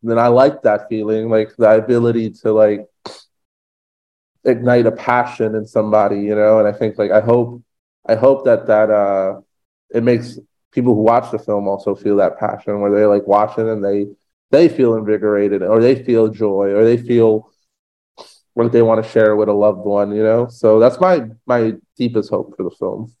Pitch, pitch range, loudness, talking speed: 110 Hz, 105-120 Hz, -15 LUFS, 195 wpm